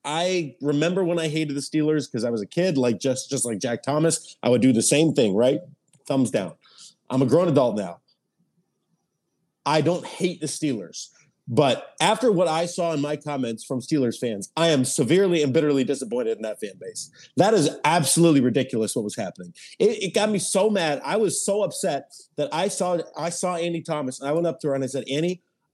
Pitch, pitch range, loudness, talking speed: 155 Hz, 135-175 Hz, -23 LUFS, 215 wpm